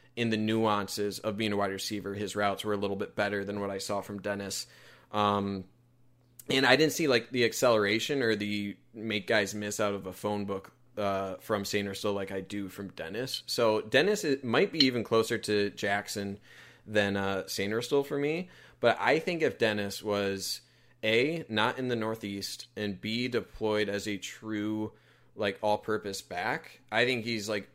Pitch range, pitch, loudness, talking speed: 100-115 Hz, 105 Hz, -30 LUFS, 190 wpm